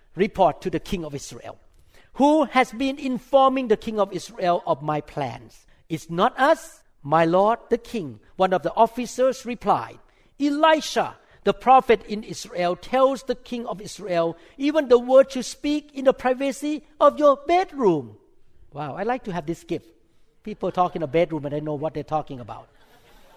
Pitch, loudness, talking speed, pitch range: 210 Hz, -22 LUFS, 175 wpm, 165-260 Hz